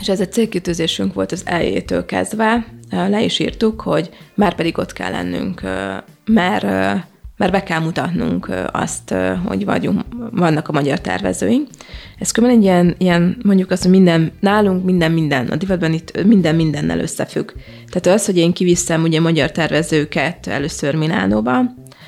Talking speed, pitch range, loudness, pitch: 160 wpm, 140-195 Hz, -17 LUFS, 165 Hz